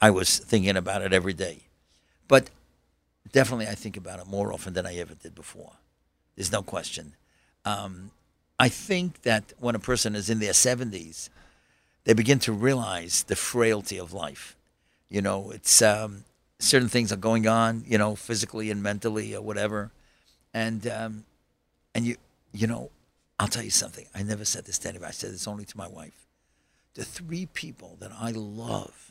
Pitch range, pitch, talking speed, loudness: 80-115 Hz, 105 Hz, 180 wpm, -26 LUFS